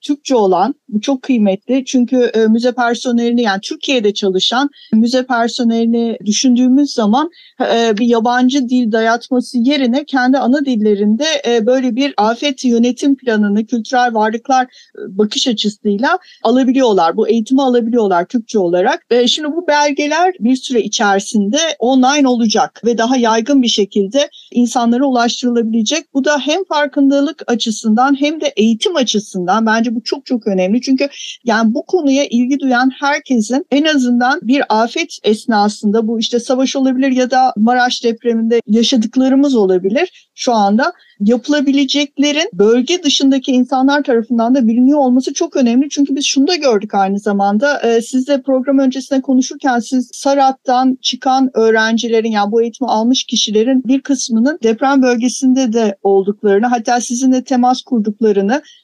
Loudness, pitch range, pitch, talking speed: -13 LUFS, 225-275 Hz, 250 Hz, 135 wpm